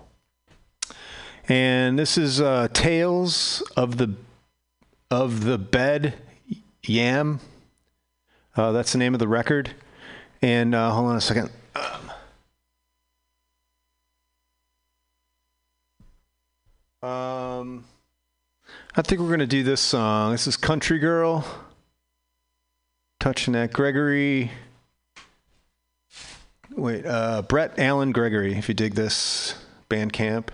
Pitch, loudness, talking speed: 115 Hz, -23 LUFS, 100 wpm